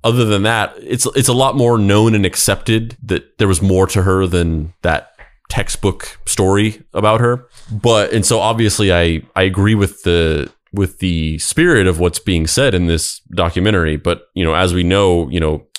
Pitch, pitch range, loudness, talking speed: 95 Hz, 85-110 Hz, -15 LUFS, 190 wpm